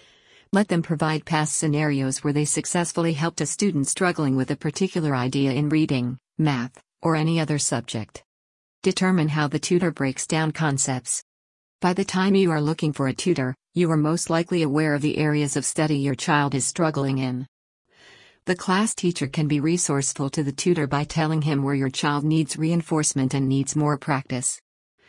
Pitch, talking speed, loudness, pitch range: 150 Hz, 180 wpm, -23 LUFS, 140-165 Hz